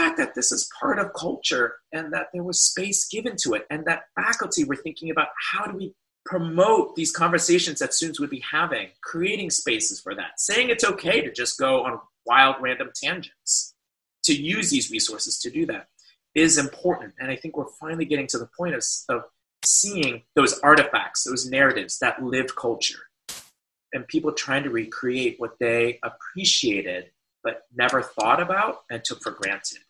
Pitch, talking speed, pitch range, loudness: 165 Hz, 180 wpm, 130-210 Hz, -23 LUFS